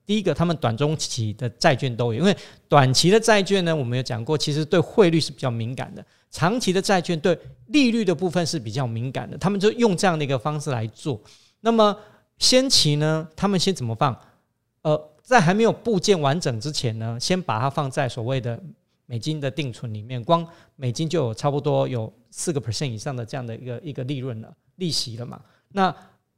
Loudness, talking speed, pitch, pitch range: -22 LUFS, 320 characters per minute, 150 Hz, 125-180 Hz